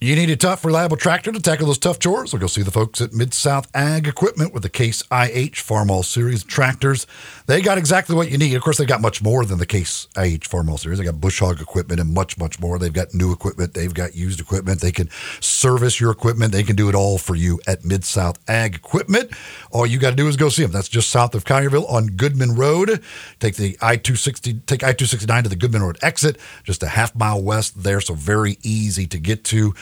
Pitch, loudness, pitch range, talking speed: 110 Hz, -19 LUFS, 95-135 Hz, 250 wpm